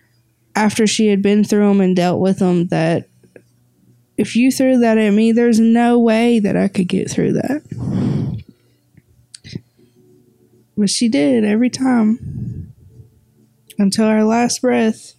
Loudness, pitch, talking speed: -15 LUFS, 205 Hz, 140 wpm